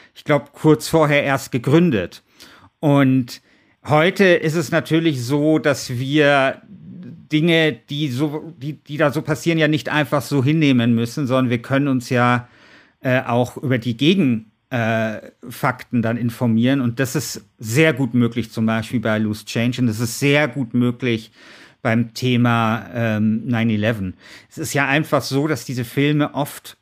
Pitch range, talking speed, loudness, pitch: 120-150 Hz, 160 wpm, -19 LUFS, 135 Hz